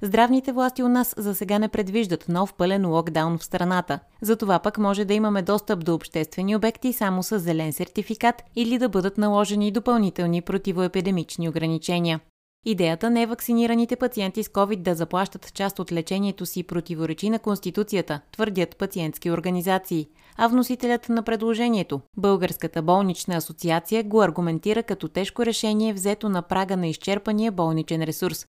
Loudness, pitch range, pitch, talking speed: -24 LUFS, 175-220 Hz, 195 Hz, 150 wpm